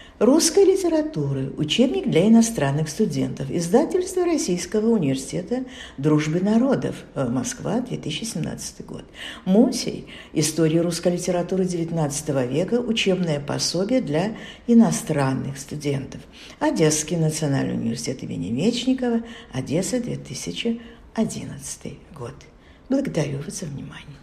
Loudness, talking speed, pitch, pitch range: -22 LUFS, 90 wpm, 180 Hz, 150-235 Hz